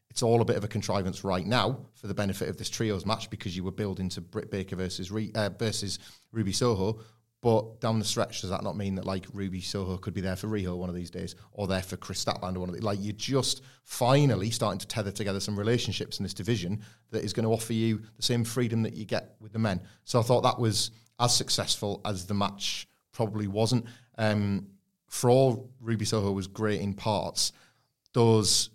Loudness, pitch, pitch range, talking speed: -29 LUFS, 110 Hz, 100-115 Hz, 225 wpm